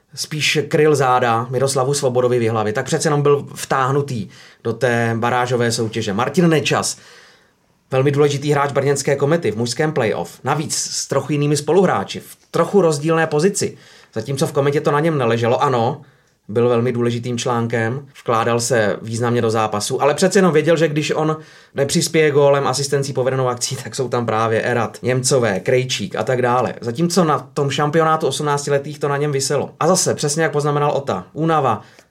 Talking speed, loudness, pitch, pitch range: 165 wpm, -18 LUFS, 140 Hz, 120-150 Hz